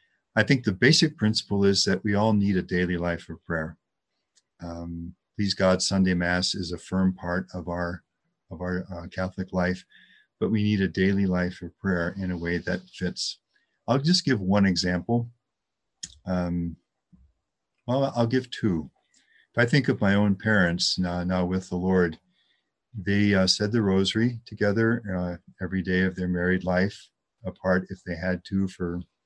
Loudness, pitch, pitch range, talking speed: -25 LUFS, 95 Hz, 90-105 Hz, 175 wpm